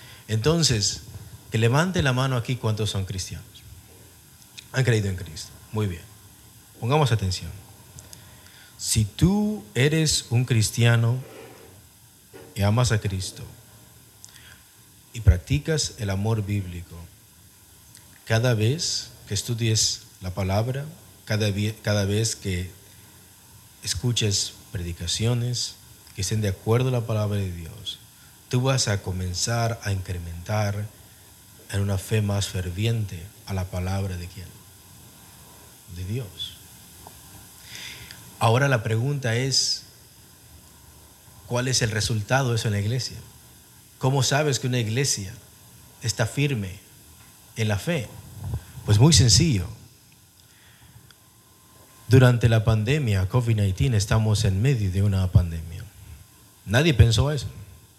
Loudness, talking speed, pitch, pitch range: -24 LUFS, 115 wpm, 110 Hz, 100-120 Hz